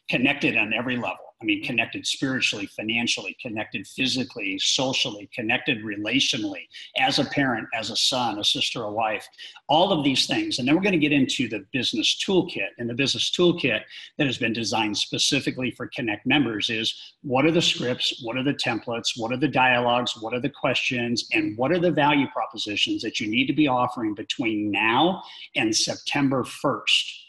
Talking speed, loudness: 185 wpm, -23 LUFS